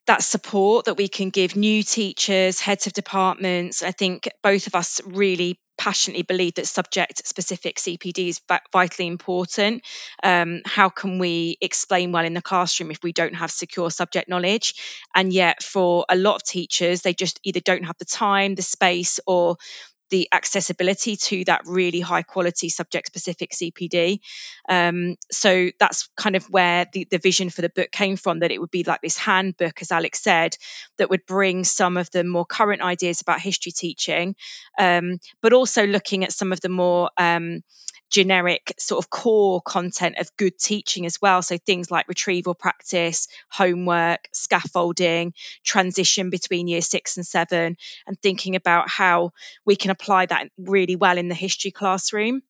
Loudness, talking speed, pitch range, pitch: -21 LUFS, 175 wpm, 175-195 Hz, 180 Hz